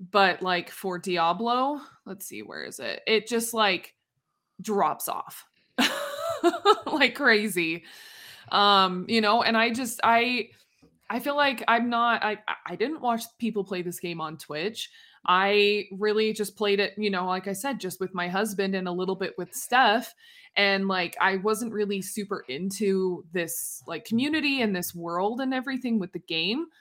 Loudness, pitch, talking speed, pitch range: -26 LUFS, 205 Hz, 170 wpm, 185-235 Hz